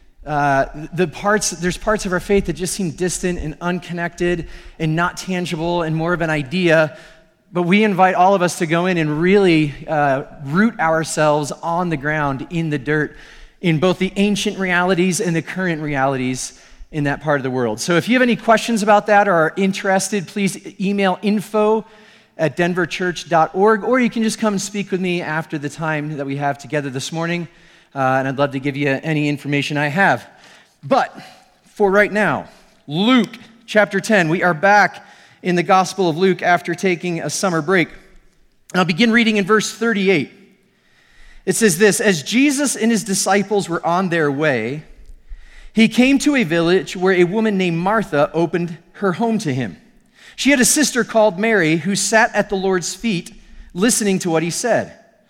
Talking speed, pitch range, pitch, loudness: 190 wpm, 160-205 Hz, 180 Hz, -17 LUFS